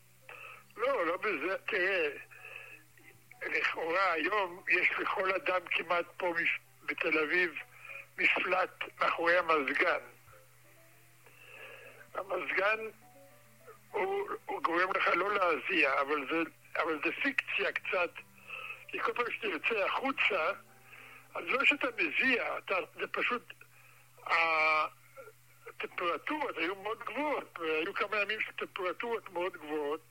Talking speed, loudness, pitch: 100 wpm, -32 LUFS, 190 Hz